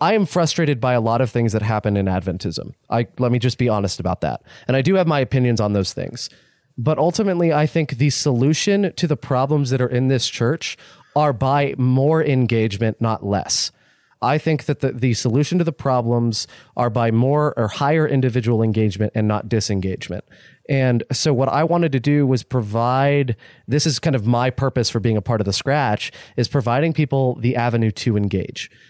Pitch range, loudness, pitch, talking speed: 115-145 Hz, -19 LUFS, 125 Hz, 200 wpm